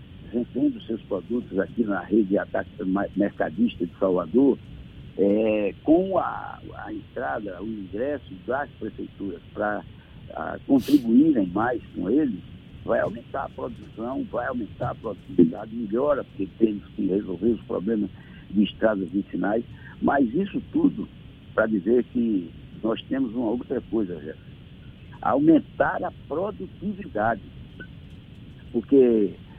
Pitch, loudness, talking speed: 120 Hz, -25 LUFS, 120 wpm